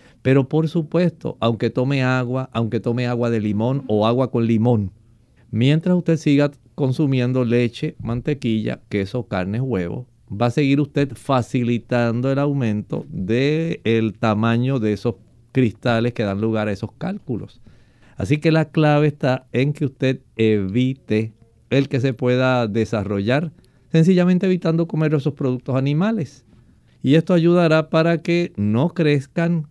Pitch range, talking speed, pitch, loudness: 115-150 Hz, 140 wpm, 130 Hz, -20 LUFS